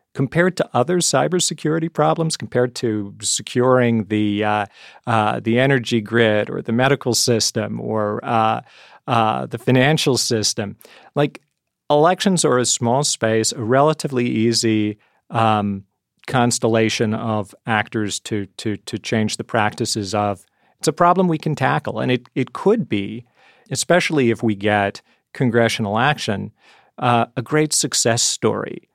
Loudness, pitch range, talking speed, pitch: -19 LUFS, 110-140 Hz, 135 wpm, 120 Hz